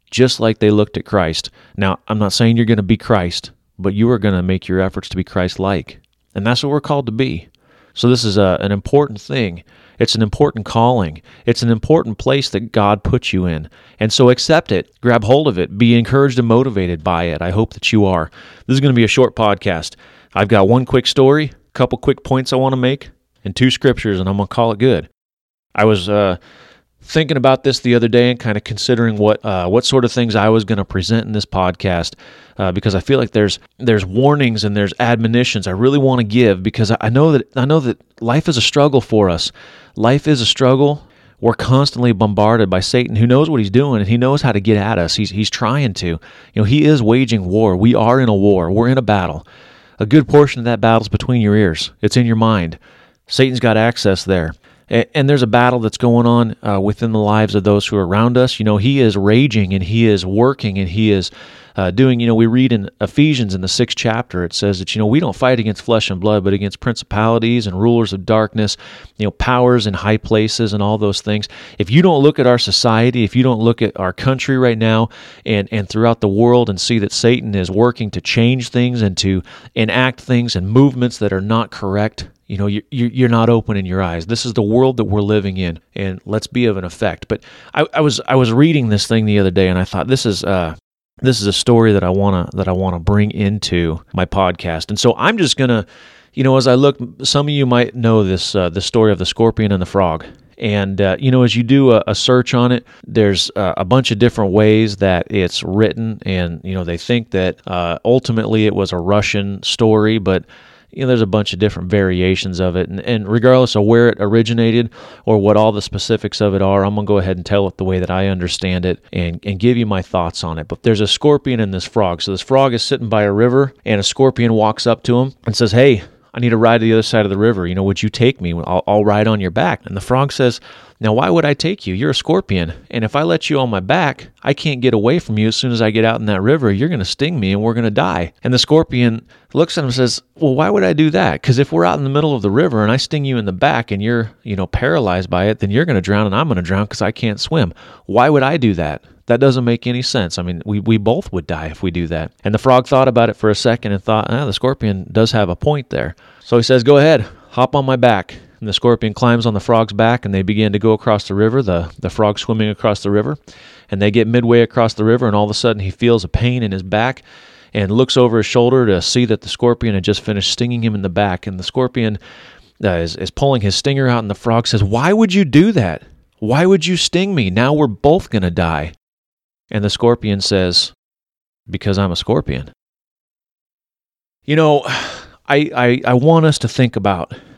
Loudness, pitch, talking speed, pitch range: -15 LUFS, 110 Hz, 255 wpm, 100-125 Hz